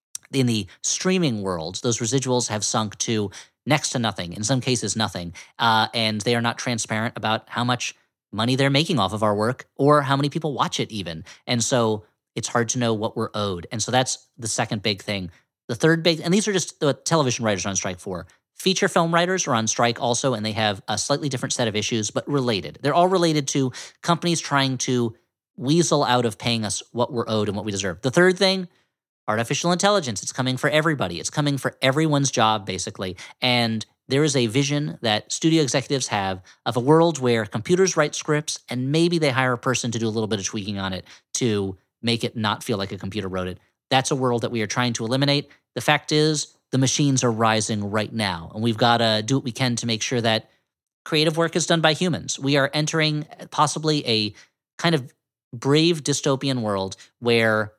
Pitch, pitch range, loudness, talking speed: 125 Hz, 110-145 Hz, -22 LUFS, 215 wpm